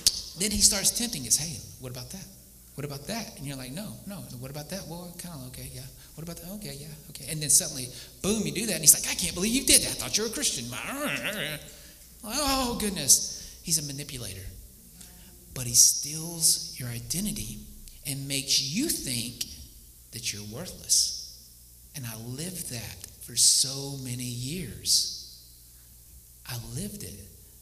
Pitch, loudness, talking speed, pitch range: 135 Hz, -25 LUFS, 175 wpm, 110-170 Hz